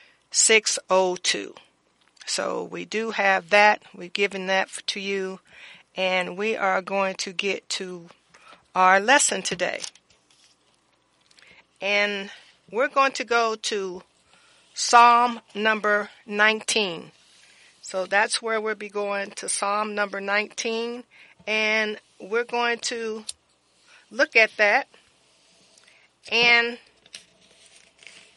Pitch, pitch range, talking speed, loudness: 210 Hz, 195-225 Hz, 100 wpm, -22 LUFS